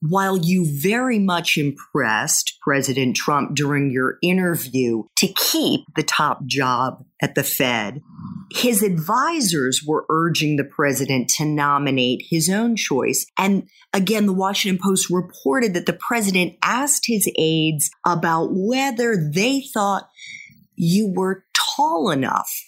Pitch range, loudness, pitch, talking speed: 145-200 Hz, -19 LUFS, 175 Hz, 130 wpm